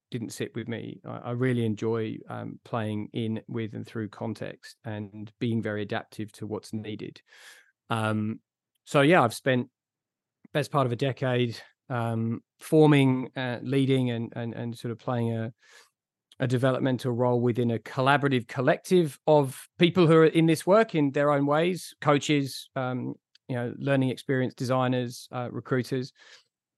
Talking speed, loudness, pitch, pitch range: 155 wpm, -27 LUFS, 125 Hz, 115-140 Hz